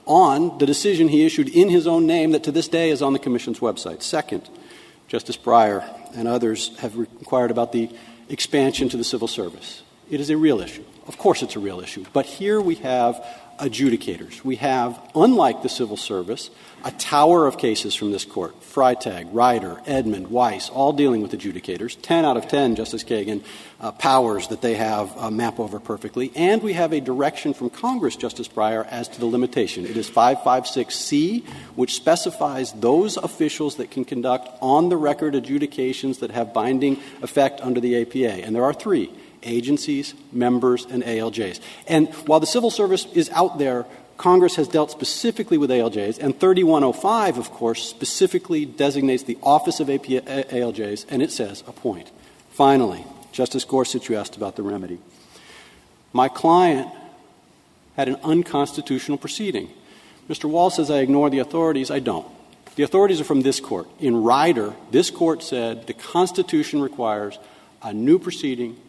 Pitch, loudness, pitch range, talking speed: 135 Hz, -21 LUFS, 120-165 Hz, 170 wpm